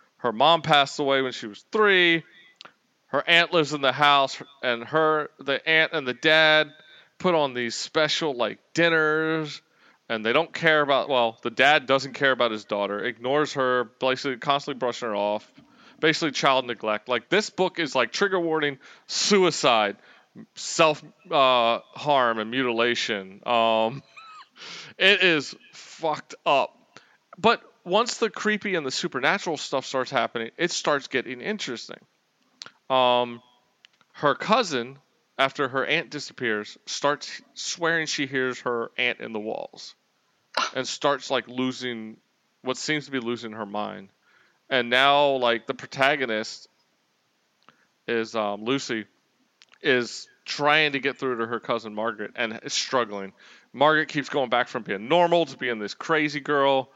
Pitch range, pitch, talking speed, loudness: 120-155 Hz, 135 Hz, 150 wpm, -24 LUFS